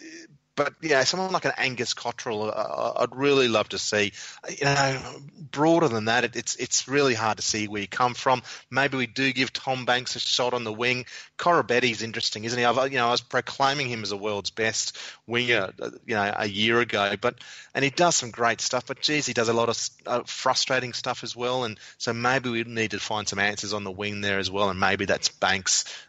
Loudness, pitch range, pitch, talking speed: -25 LUFS, 110-130 Hz, 120 Hz, 230 wpm